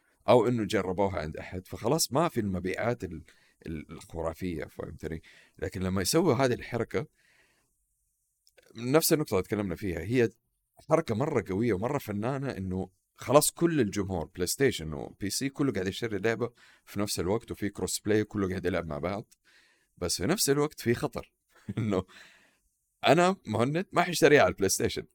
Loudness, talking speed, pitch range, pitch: -29 LUFS, 155 wpm, 90-125 Hz, 100 Hz